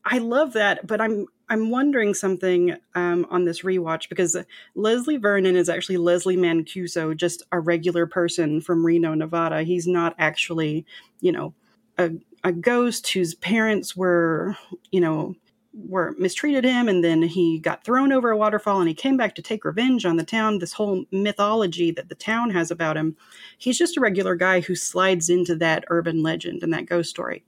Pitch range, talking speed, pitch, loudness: 170-220 Hz, 185 wpm, 180 Hz, -22 LUFS